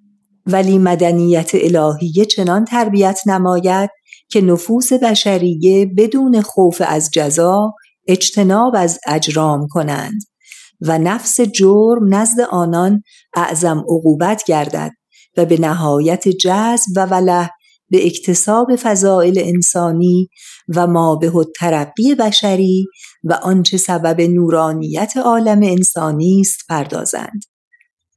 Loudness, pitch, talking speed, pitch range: -13 LUFS, 185 Hz, 100 wpm, 170-210 Hz